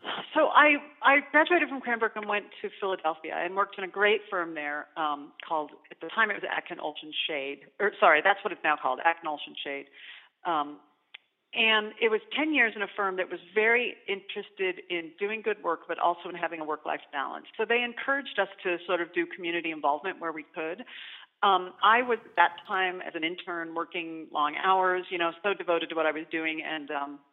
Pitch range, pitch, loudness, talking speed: 160-210 Hz, 180 Hz, -28 LUFS, 215 wpm